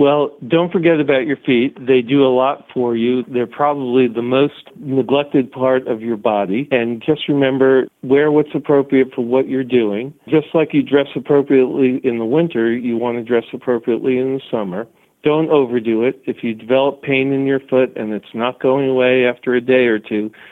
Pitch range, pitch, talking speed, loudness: 125-140 Hz, 130 Hz, 195 wpm, -16 LUFS